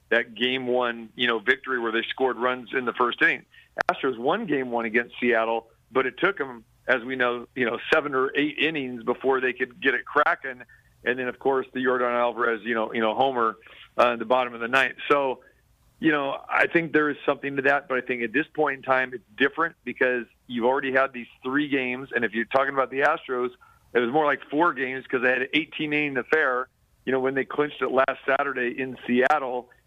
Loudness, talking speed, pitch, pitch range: -25 LUFS, 230 wpm, 125 Hz, 120-135 Hz